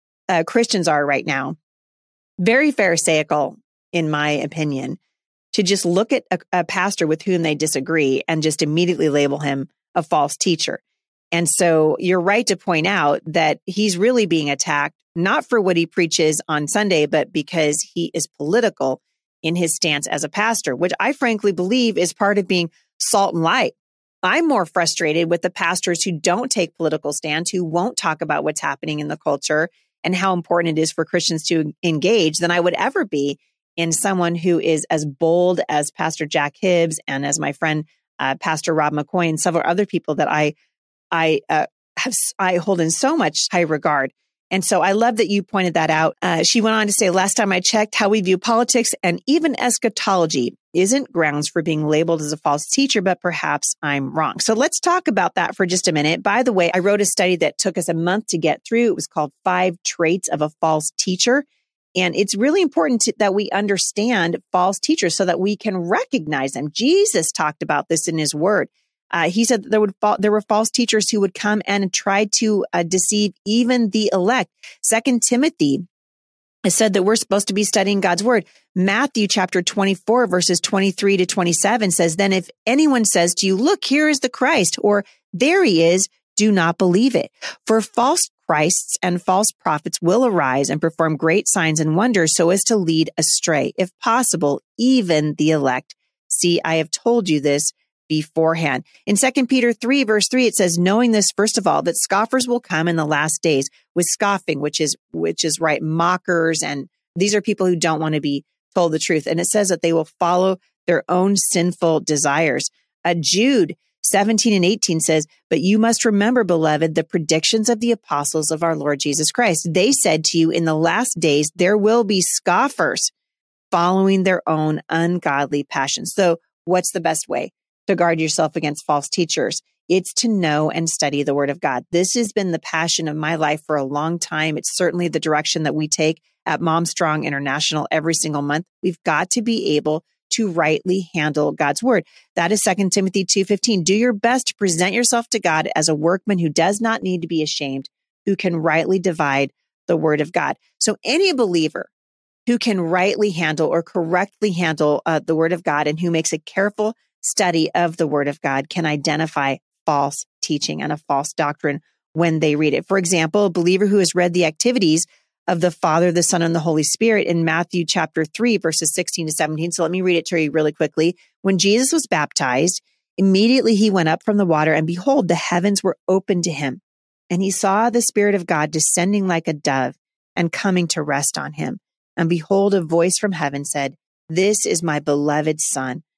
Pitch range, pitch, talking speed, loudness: 155-205 Hz, 175 Hz, 200 wpm, -18 LUFS